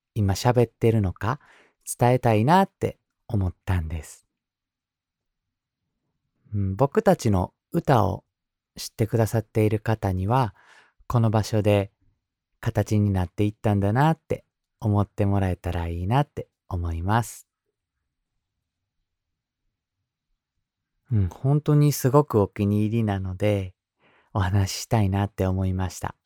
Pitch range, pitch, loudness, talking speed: 95-120 Hz, 105 Hz, -24 LUFS, 255 characters per minute